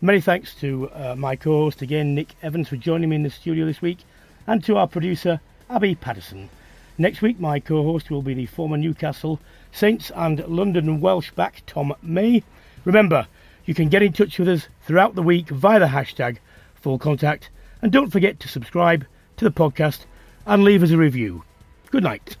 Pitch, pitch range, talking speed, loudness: 160 Hz, 140-185 Hz, 190 wpm, -20 LUFS